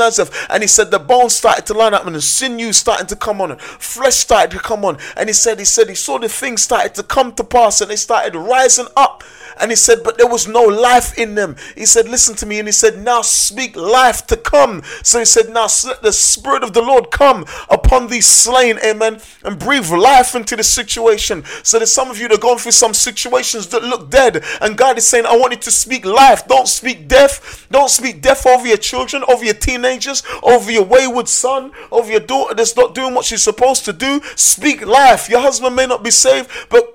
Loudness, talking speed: -12 LUFS, 235 wpm